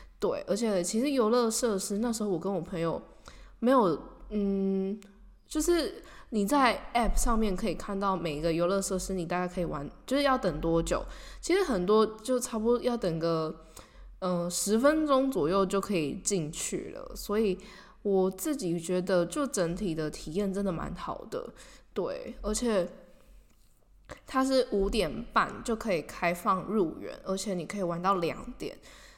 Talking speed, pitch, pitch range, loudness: 245 characters per minute, 200 Hz, 180-235 Hz, -30 LUFS